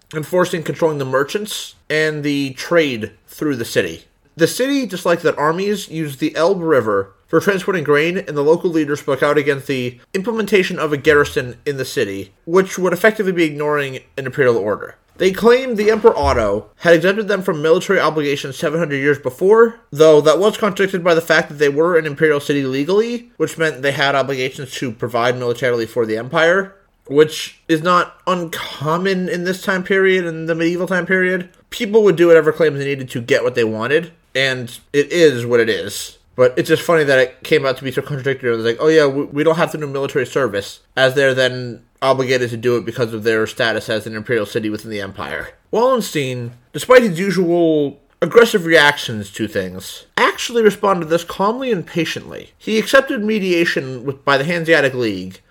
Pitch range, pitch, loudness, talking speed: 135-185 Hz, 155 Hz, -16 LUFS, 195 wpm